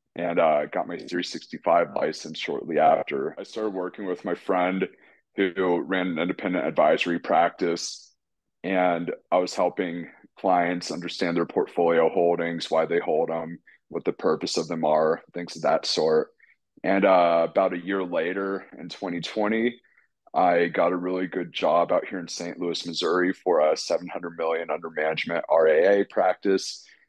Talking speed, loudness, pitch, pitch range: 160 wpm, -25 LUFS, 90 Hz, 85-95 Hz